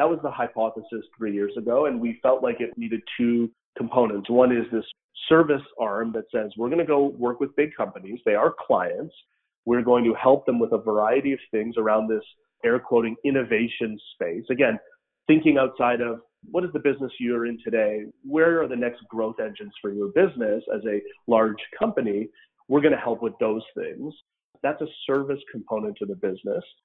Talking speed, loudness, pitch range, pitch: 190 wpm, -24 LUFS, 115-150 Hz, 120 Hz